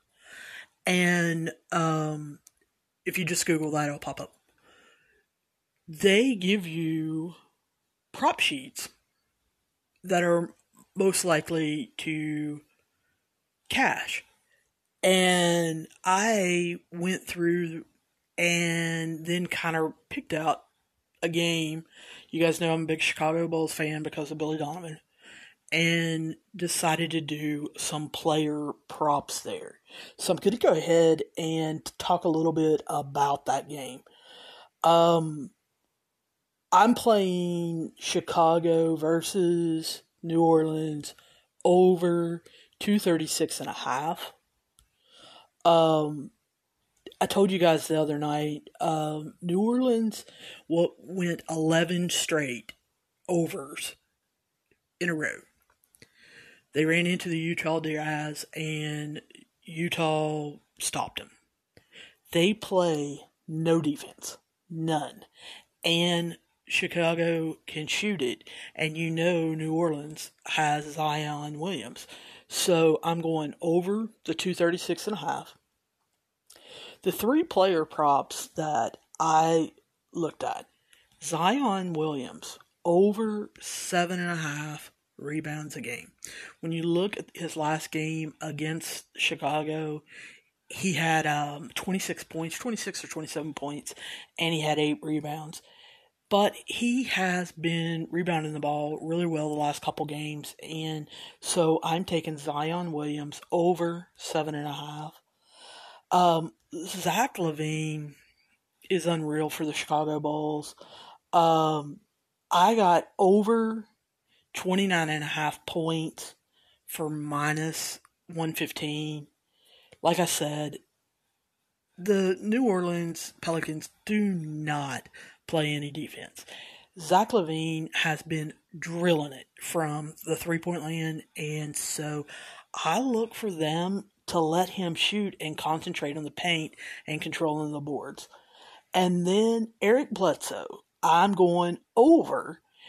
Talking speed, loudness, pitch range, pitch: 110 wpm, -27 LUFS, 155-175 Hz, 165 Hz